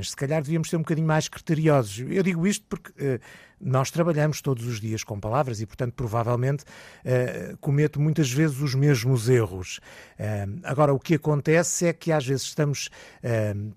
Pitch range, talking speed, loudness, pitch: 120-160 Hz, 180 wpm, -25 LUFS, 140 Hz